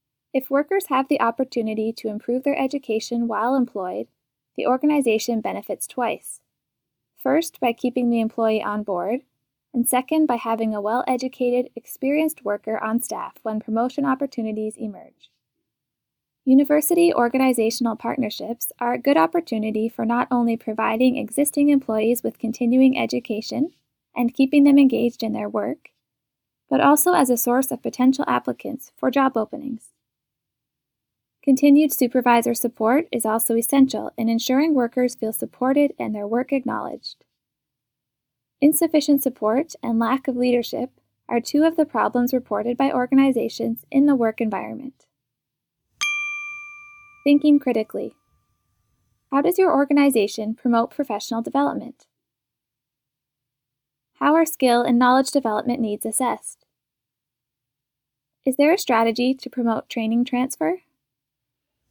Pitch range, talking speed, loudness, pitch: 225-280 Hz, 125 wpm, -21 LUFS, 245 Hz